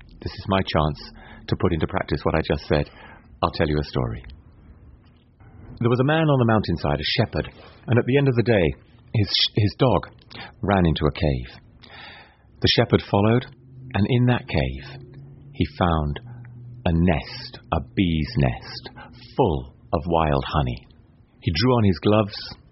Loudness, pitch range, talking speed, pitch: -22 LUFS, 80-120 Hz, 170 wpm, 100 Hz